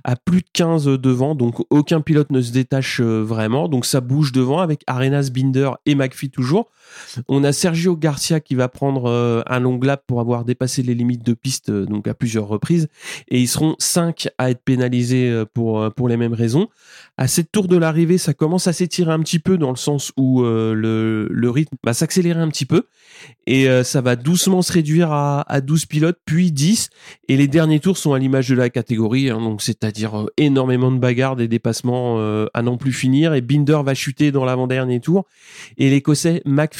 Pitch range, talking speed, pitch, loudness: 125-155 Hz, 200 wpm, 135 Hz, -18 LUFS